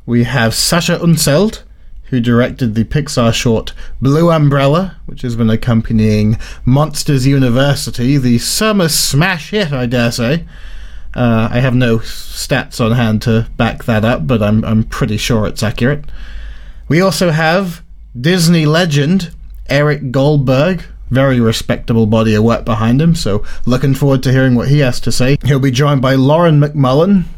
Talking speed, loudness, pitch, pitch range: 160 wpm, -12 LUFS, 130 Hz, 115-150 Hz